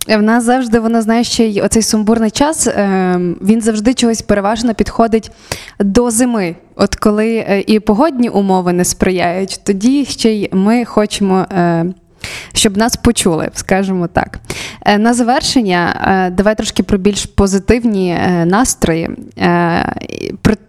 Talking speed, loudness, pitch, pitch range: 125 wpm, -13 LUFS, 215 Hz, 190-230 Hz